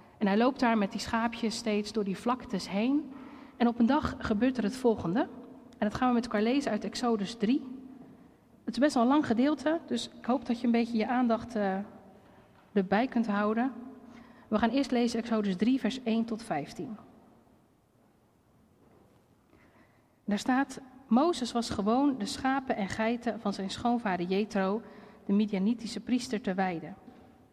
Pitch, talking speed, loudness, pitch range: 235 Hz, 170 wpm, -30 LUFS, 210-250 Hz